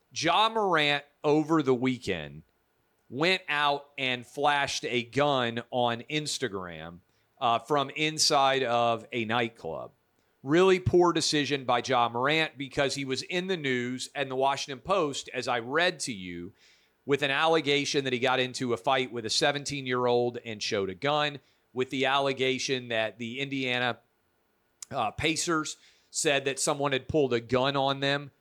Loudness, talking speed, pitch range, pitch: -27 LUFS, 160 wpm, 120-145 Hz, 135 Hz